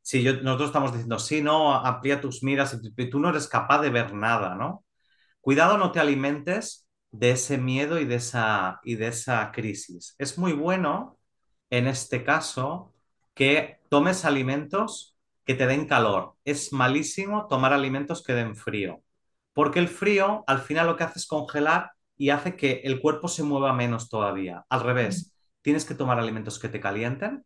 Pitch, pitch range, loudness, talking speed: 135 Hz, 120-155 Hz, -25 LUFS, 175 wpm